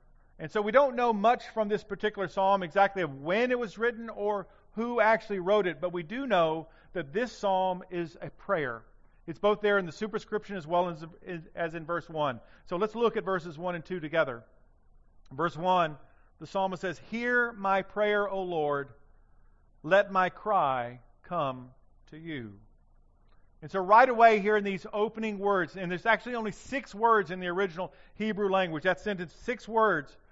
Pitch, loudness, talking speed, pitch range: 190 Hz, -29 LUFS, 185 wpm, 165-210 Hz